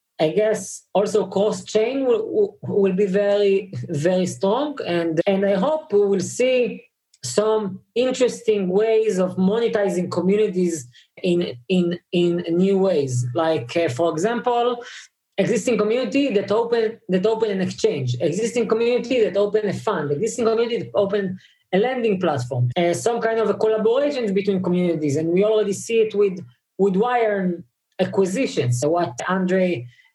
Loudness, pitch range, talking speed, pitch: -21 LUFS, 180-225 Hz, 145 wpm, 200 Hz